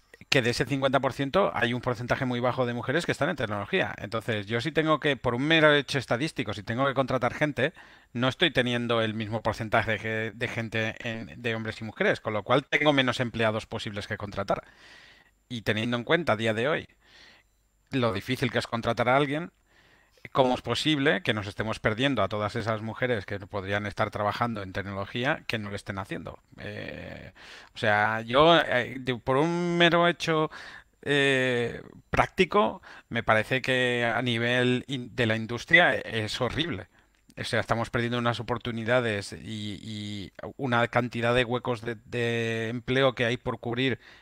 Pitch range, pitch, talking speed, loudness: 110-130 Hz, 120 Hz, 180 wpm, -27 LUFS